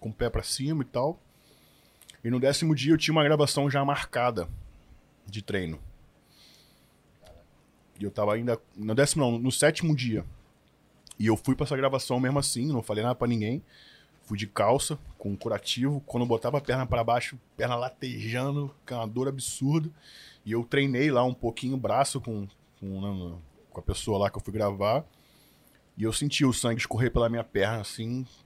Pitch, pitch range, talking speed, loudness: 120 Hz, 110-140 Hz, 185 wpm, -28 LUFS